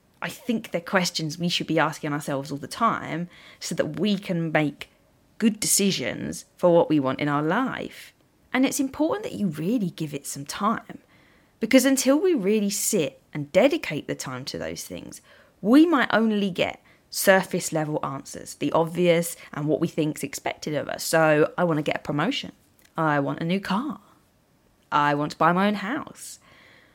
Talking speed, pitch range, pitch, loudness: 185 wpm, 155-210 Hz, 170 Hz, -24 LUFS